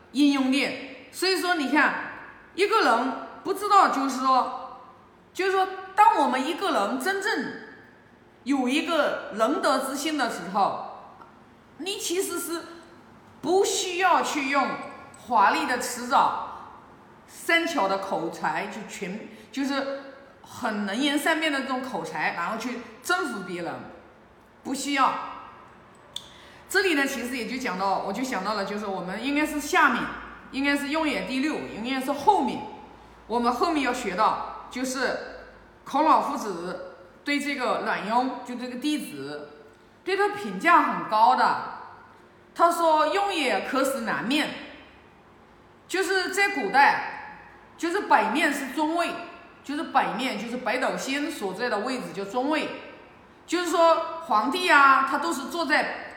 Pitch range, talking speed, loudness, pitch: 245-340 Hz, 205 characters per minute, -25 LUFS, 280 Hz